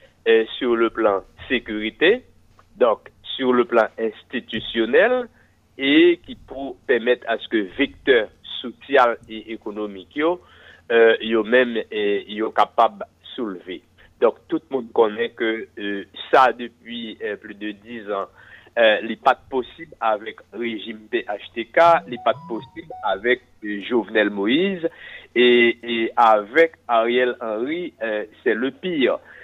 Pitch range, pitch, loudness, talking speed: 110-165 Hz, 120 Hz, -21 LUFS, 130 wpm